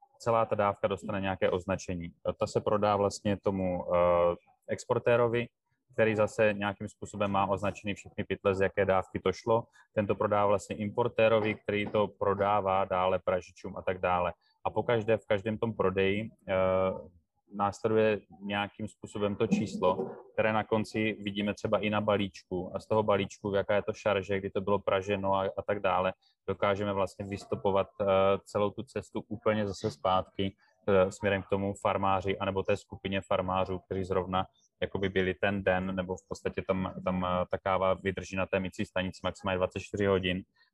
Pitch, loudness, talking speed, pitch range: 100 Hz, -31 LUFS, 165 wpm, 95-105 Hz